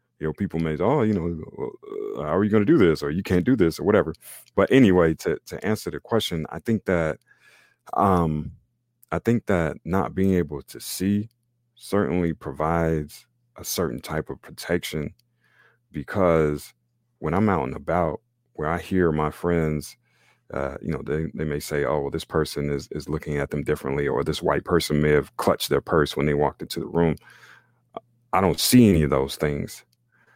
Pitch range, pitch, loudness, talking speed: 75-110 Hz, 85 Hz, -24 LUFS, 190 wpm